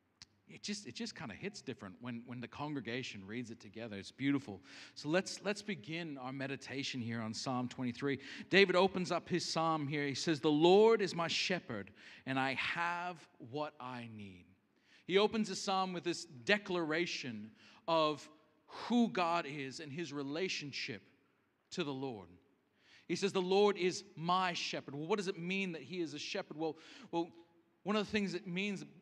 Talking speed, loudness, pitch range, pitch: 180 wpm, -37 LUFS, 130-185 Hz, 160 Hz